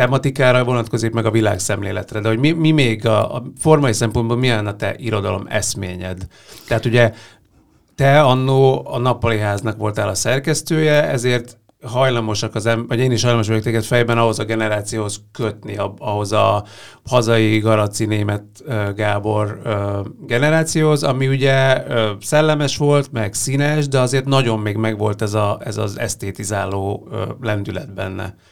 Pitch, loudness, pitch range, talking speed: 115 Hz, -18 LUFS, 105-130 Hz, 145 wpm